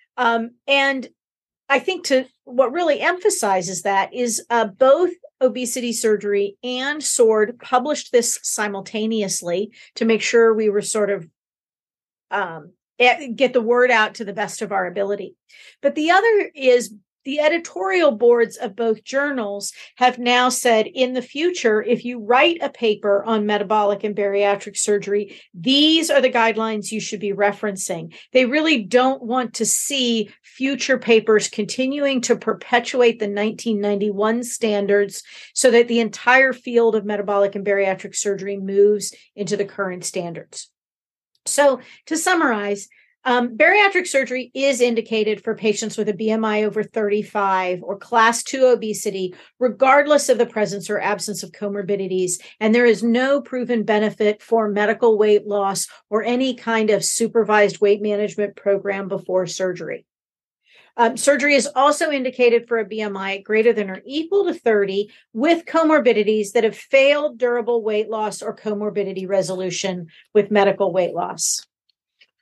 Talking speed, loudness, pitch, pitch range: 145 wpm, -19 LUFS, 225 Hz, 205-255 Hz